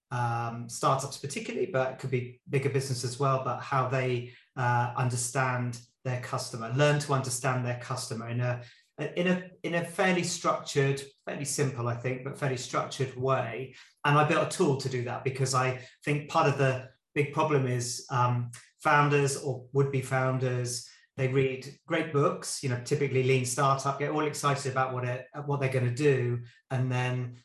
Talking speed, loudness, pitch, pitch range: 180 wpm, -29 LUFS, 130 Hz, 125-145 Hz